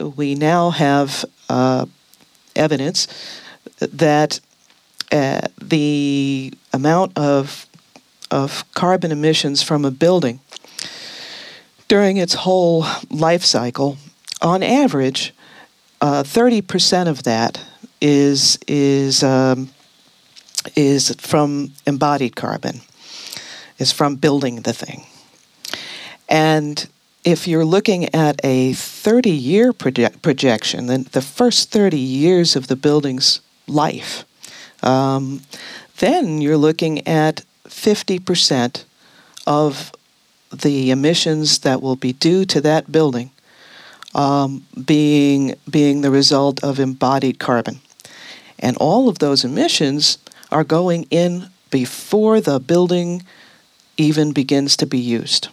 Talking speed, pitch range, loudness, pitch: 105 wpm, 135-170 Hz, -16 LUFS, 145 Hz